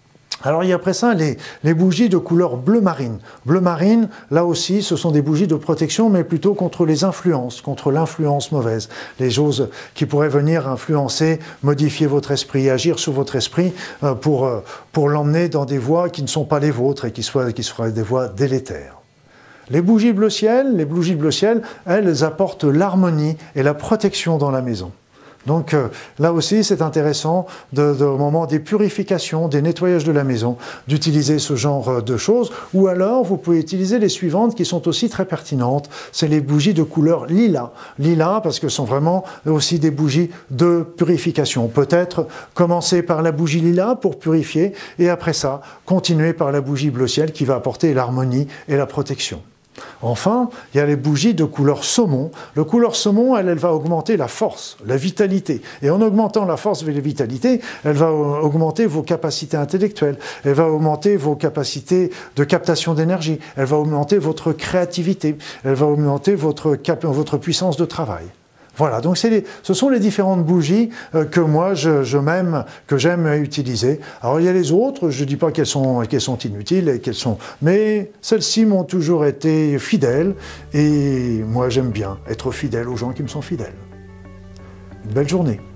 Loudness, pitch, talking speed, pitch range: -18 LUFS, 155 Hz, 190 wpm, 140-180 Hz